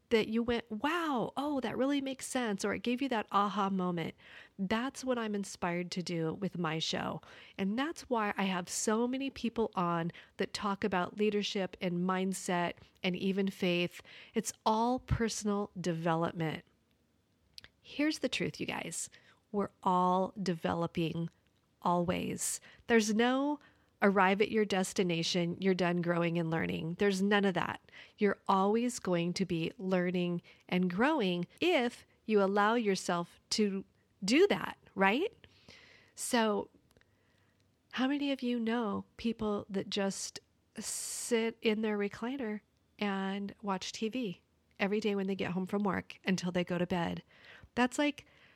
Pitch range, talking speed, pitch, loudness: 180-225 Hz, 145 wpm, 195 Hz, -33 LUFS